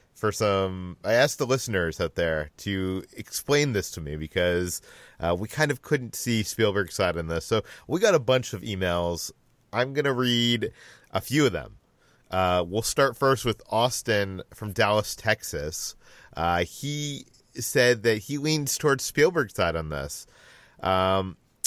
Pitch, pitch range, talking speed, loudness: 105 Hz, 90-130 Hz, 165 wpm, -26 LUFS